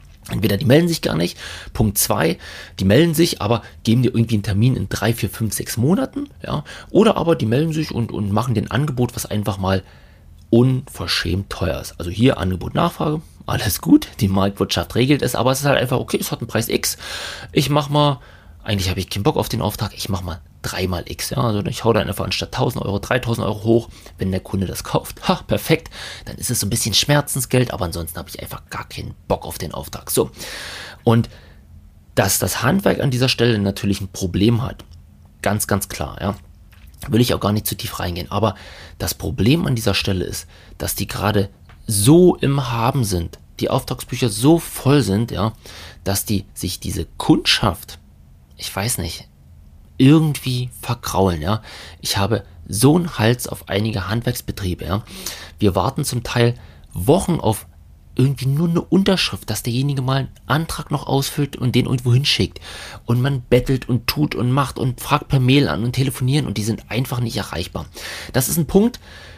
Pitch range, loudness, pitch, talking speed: 95-130 Hz, -19 LUFS, 110 Hz, 195 wpm